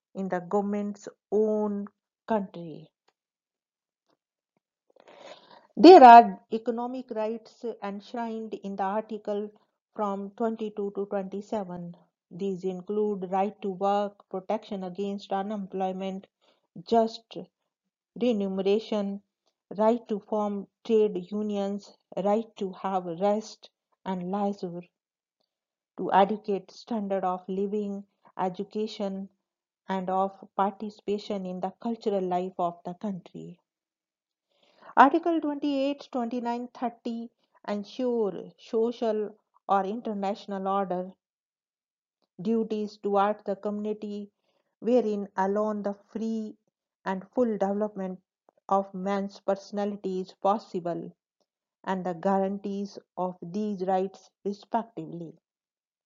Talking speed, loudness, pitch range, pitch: 90 wpm, -27 LUFS, 190-215 Hz, 200 Hz